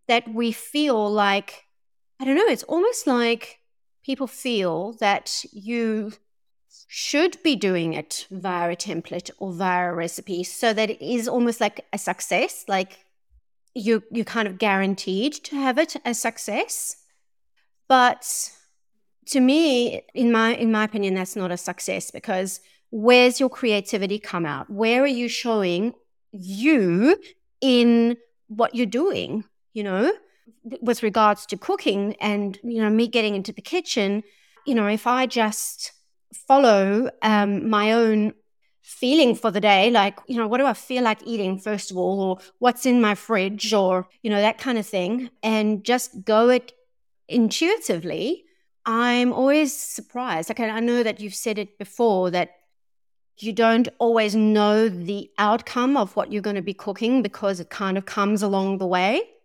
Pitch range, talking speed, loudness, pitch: 200-245 Hz, 165 wpm, -22 LUFS, 220 Hz